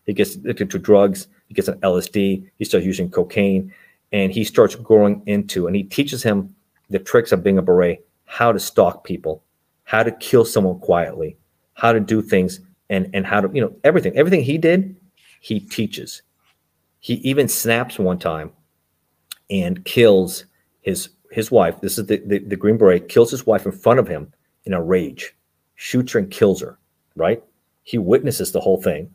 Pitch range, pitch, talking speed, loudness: 90-110 Hz, 100 Hz, 185 wpm, -18 LUFS